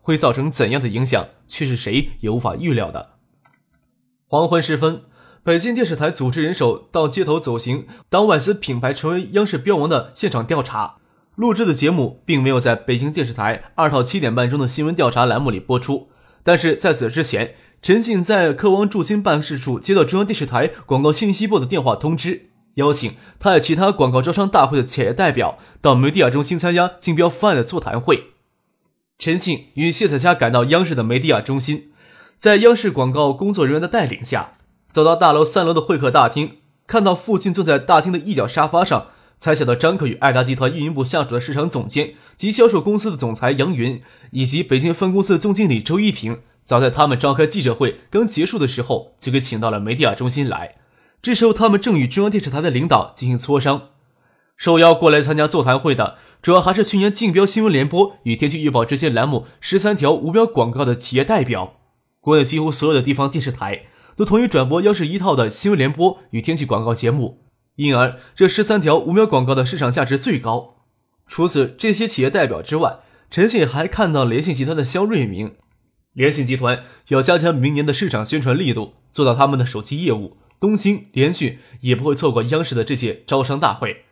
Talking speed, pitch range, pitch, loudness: 320 characters per minute, 125-175 Hz, 150 Hz, -17 LUFS